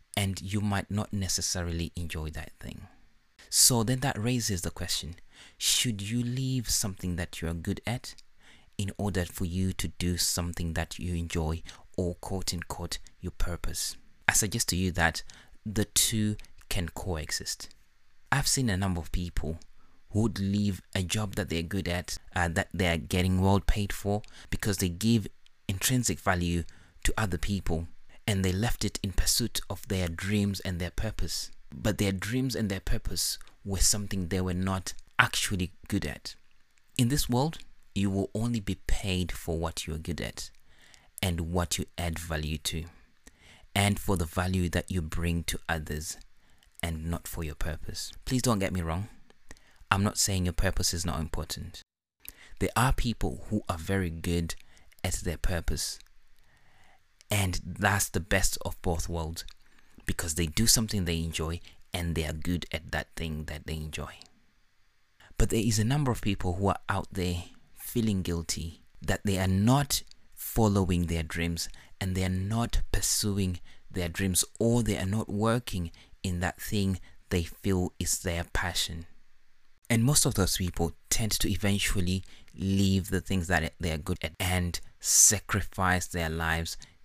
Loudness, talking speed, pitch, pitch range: -30 LUFS, 170 wpm, 95 Hz, 85-105 Hz